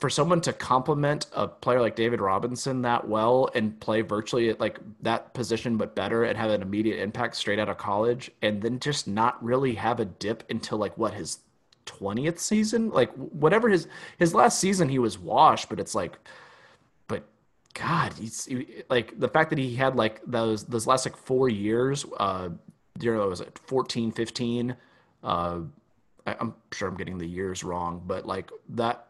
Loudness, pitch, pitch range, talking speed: -27 LUFS, 120 Hz, 105-130 Hz, 190 wpm